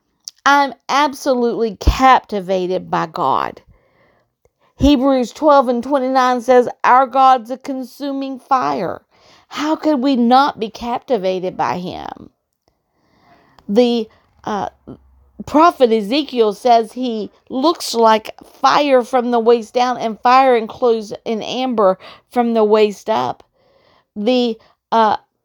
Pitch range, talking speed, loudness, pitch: 225-270 Hz, 115 wpm, -16 LUFS, 250 Hz